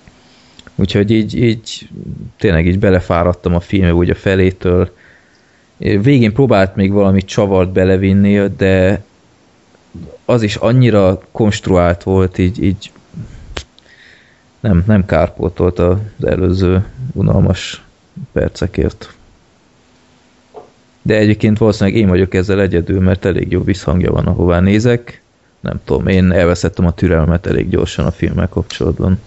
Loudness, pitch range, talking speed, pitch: -13 LUFS, 90-105 Hz, 120 wpm, 95 Hz